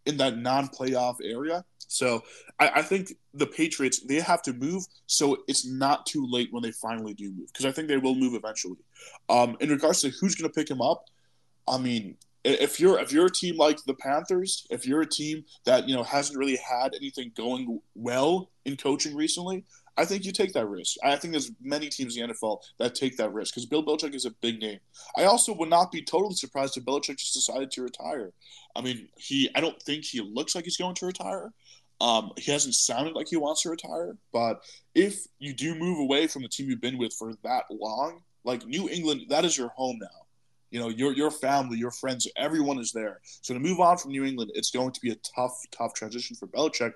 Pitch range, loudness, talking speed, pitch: 125-160 Hz, -28 LUFS, 225 wpm, 135 Hz